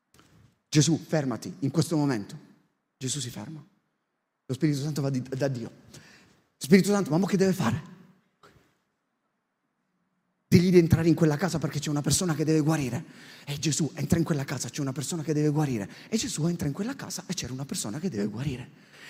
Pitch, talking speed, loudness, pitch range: 155 Hz, 185 wpm, -27 LUFS, 140-175 Hz